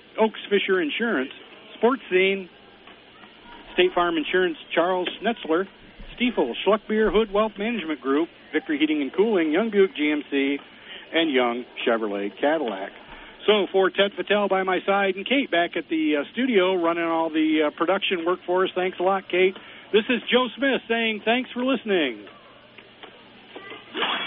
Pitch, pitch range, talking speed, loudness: 190 Hz, 170-225 Hz, 150 wpm, -23 LUFS